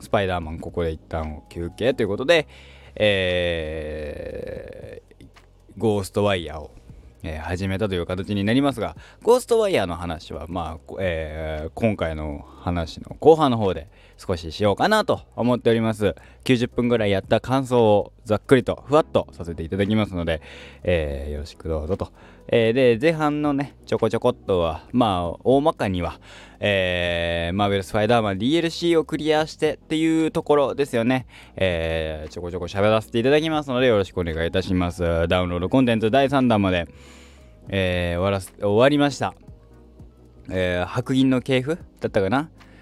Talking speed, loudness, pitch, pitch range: 355 characters per minute, -22 LUFS, 100 Hz, 85-125 Hz